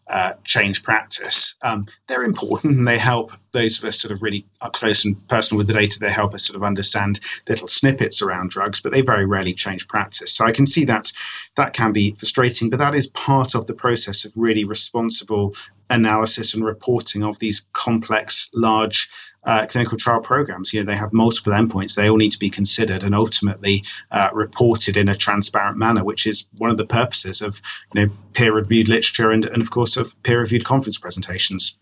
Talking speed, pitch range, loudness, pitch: 200 wpm, 105-115 Hz, -19 LUFS, 110 Hz